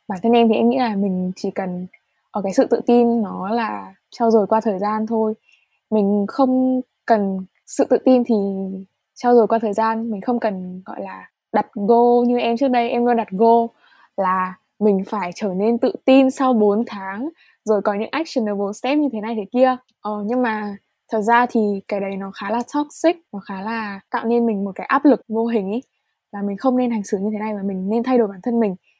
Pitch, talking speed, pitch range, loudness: 225 Hz, 230 wpm, 200-240 Hz, -19 LUFS